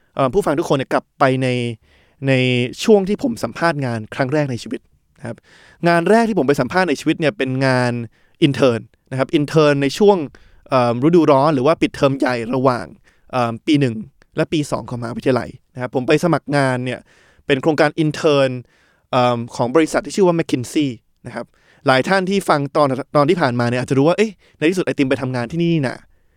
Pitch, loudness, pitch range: 140 Hz, -17 LUFS, 125-160 Hz